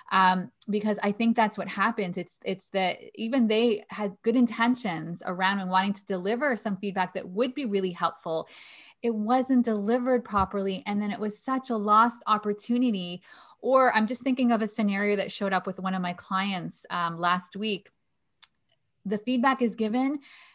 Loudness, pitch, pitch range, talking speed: -27 LUFS, 210 Hz, 190-235 Hz, 180 wpm